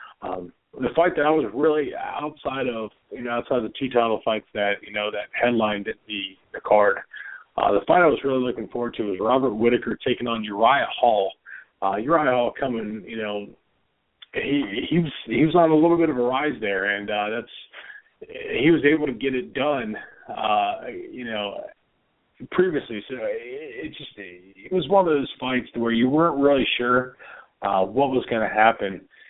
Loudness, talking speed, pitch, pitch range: -23 LUFS, 195 wpm, 125 Hz, 110-160 Hz